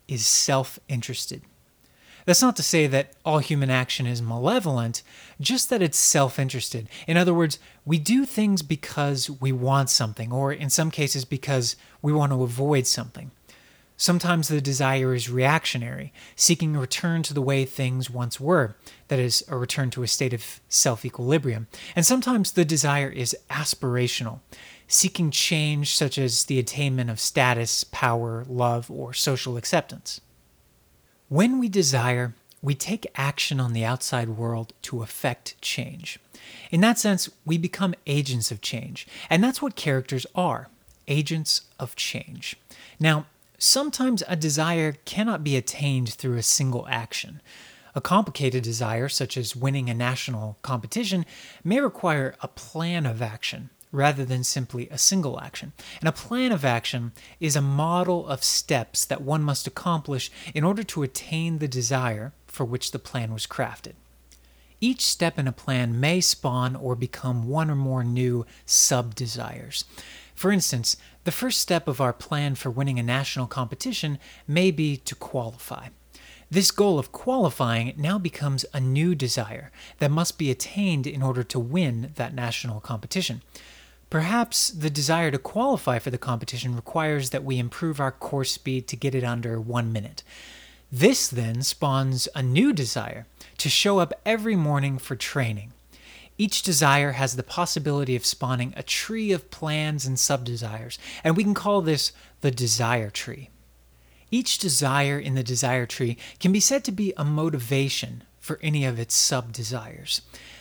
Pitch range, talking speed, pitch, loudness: 125-160 Hz, 160 wpm, 135 Hz, -24 LUFS